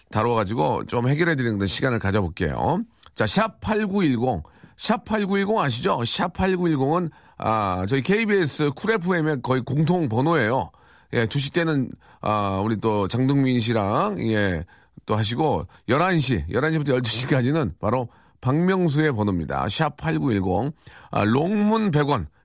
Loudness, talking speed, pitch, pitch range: -22 LUFS, 240 characters per minute, 135 Hz, 110-165 Hz